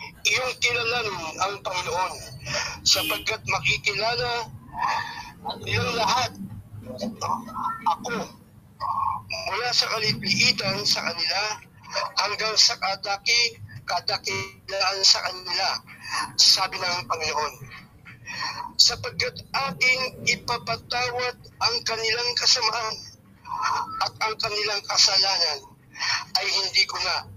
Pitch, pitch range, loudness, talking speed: 225 Hz, 190-245 Hz, -23 LUFS, 80 wpm